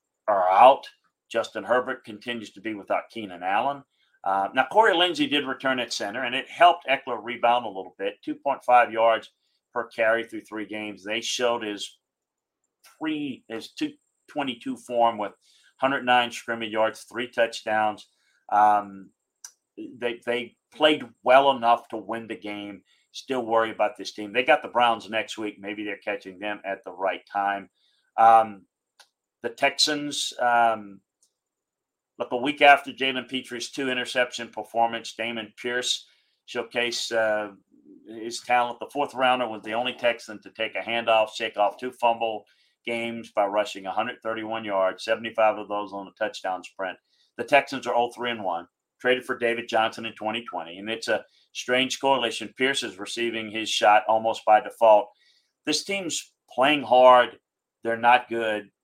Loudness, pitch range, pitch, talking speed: -24 LUFS, 105-125 Hz, 115 Hz, 155 wpm